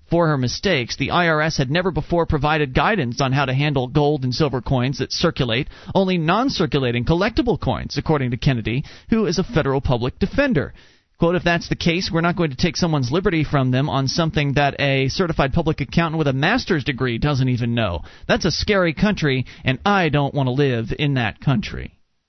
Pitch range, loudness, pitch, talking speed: 135-170 Hz, -20 LUFS, 150 Hz, 200 wpm